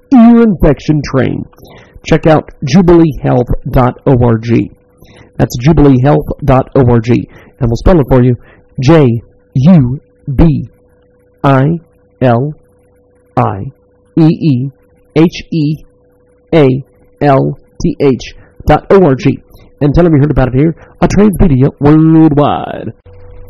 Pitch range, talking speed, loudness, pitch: 100-155 Hz, 70 wpm, -10 LUFS, 135 Hz